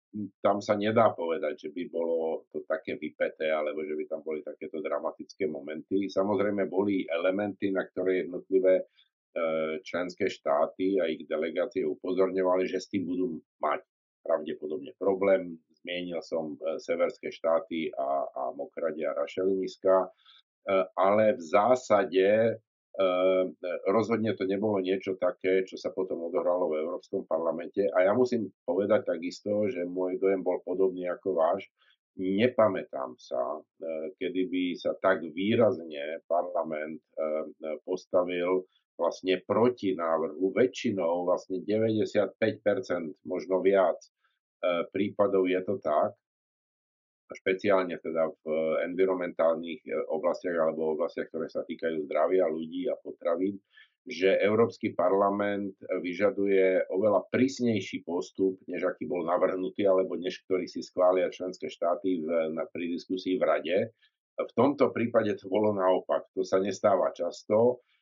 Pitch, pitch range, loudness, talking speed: 95 Hz, 85-100 Hz, -29 LUFS, 130 wpm